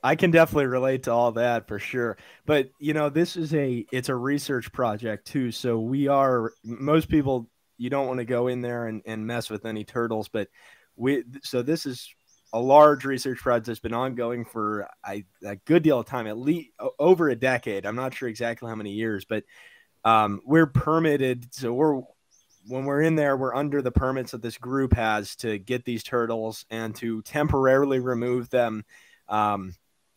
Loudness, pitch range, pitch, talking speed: -25 LUFS, 110-135 Hz, 125 Hz, 195 wpm